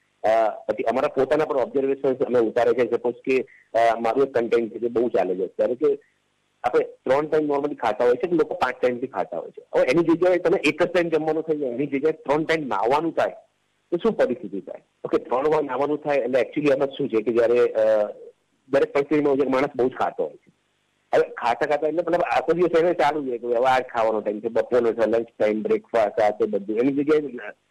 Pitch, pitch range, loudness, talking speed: 145 Hz, 120-175 Hz, -22 LUFS, 220 wpm